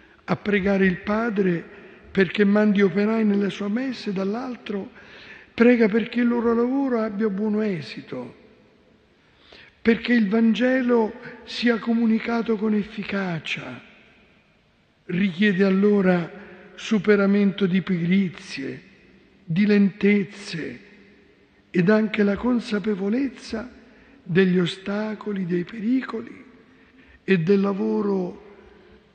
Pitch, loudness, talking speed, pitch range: 205 Hz, -22 LUFS, 90 wpm, 195-230 Hz